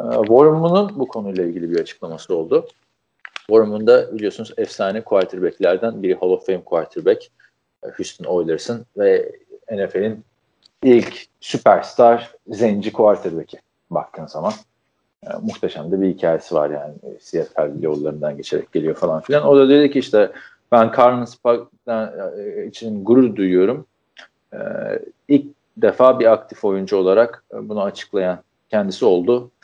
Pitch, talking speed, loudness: 130 Hz, 125 wpm, -18 LUFS